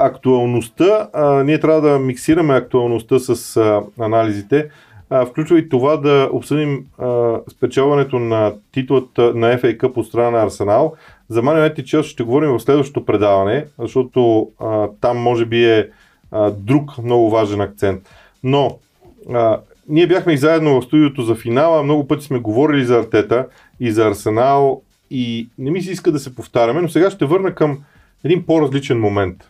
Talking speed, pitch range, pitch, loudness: 165 wpm, 115-150 Hz, 130 Hz, -16 LUFS